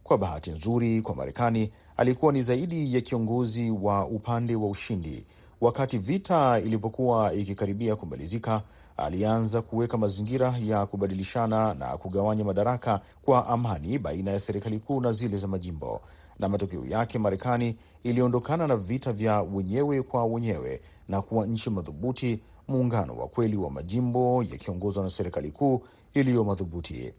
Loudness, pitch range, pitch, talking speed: -28 LUFS, 100-120 Hz, 110 Hz, 140 wpm